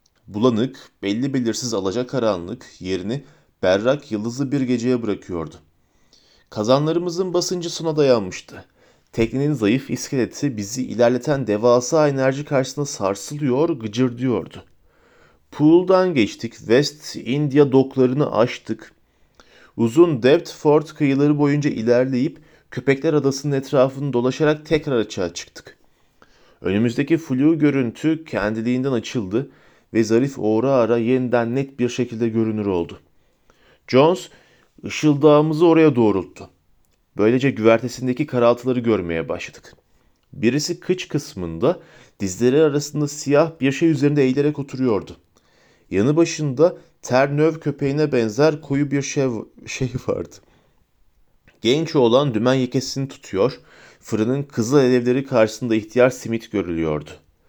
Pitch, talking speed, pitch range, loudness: 130 Hz, 105 wpm, 115-145 Hz, -20 LUFS